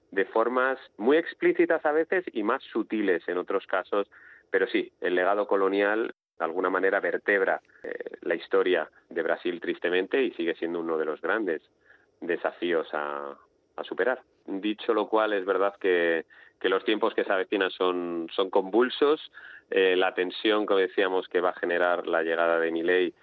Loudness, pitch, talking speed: -27 LUFS, 105 Hz, 170 wpm